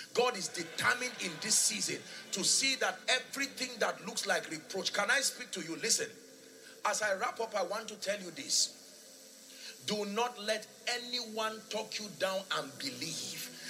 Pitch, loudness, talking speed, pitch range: 225 Hz, -33 LUFS, 170 wpm, 205-245 Hz